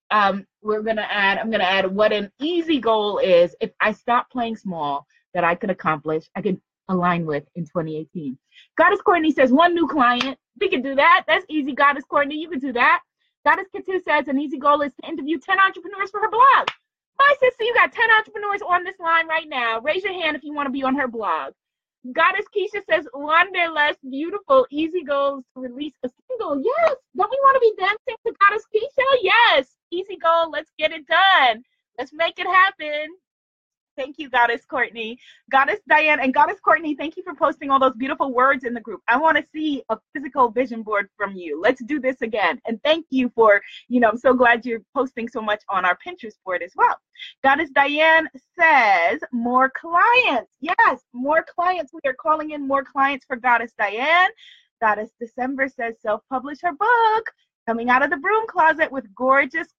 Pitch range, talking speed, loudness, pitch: 240-345 Hz, 205 wpm, -20 LUFS, 290 Hz